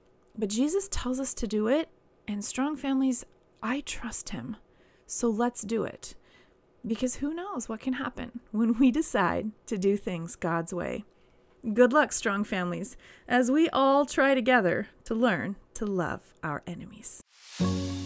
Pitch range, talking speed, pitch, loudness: 210-265 Hz, 155 wpm, 240 Hz, -28 LUFS